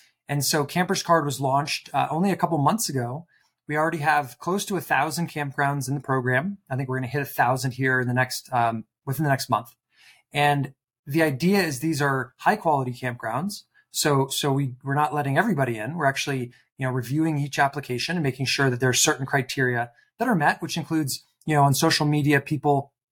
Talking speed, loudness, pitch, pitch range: 215 wpm, -24 LUFS, 140 Hz, 130-155 Hz